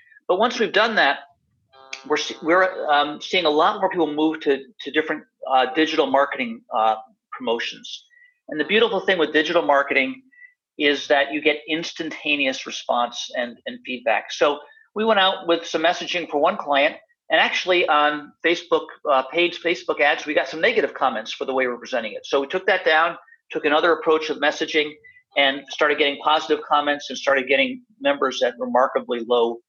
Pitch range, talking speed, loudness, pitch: 145-220 Hz, 180 wpm, -21 LUFS, 155 Hz